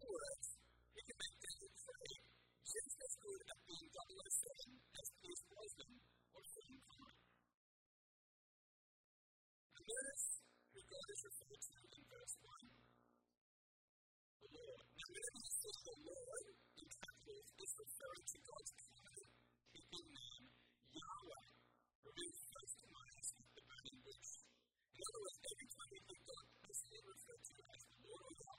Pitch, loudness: 395 Hz, -53 LUFS